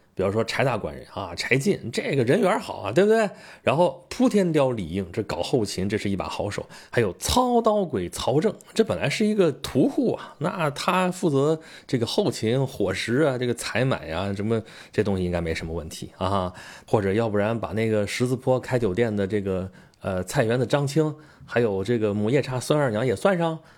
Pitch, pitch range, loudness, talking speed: 120 Hz, 100-160 Hz, -24 LUFS, 295 characters per minute